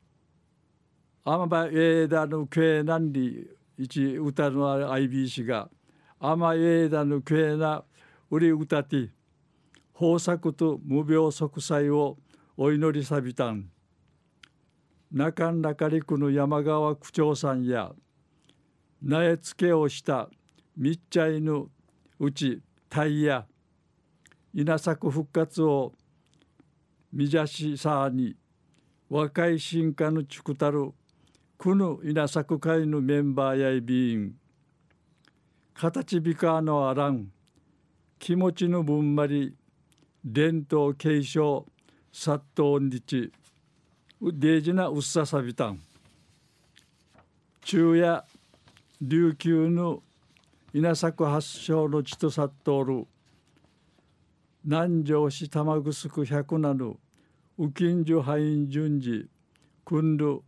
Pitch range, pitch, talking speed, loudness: 140-160 Hz, 150 Hz, 185 characters per minute, -26 LUFS